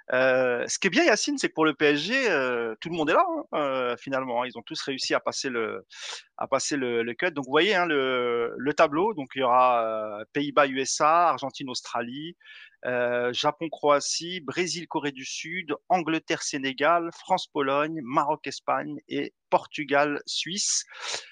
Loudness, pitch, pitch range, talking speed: -26 LUFS, 145 Hz, 125-165 Hz, 180 wpm